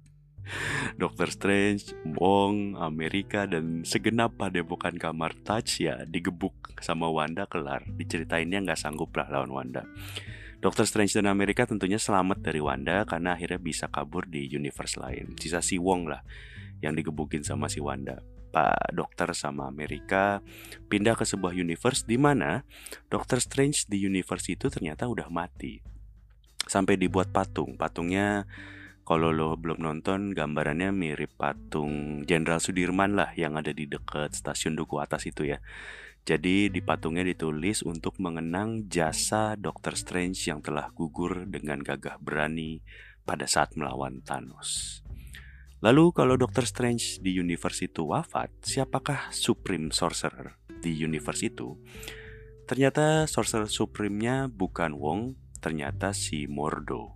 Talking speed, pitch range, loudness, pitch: 130 wpm, 80-105 Hz, -29 LUFS, 90 Hz